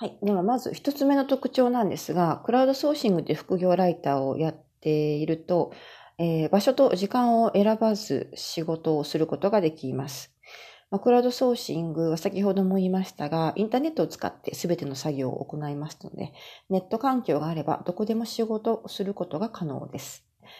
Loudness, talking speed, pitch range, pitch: -26 LUFS, 380 characters per minute, 160-225 Hz, 185 Hz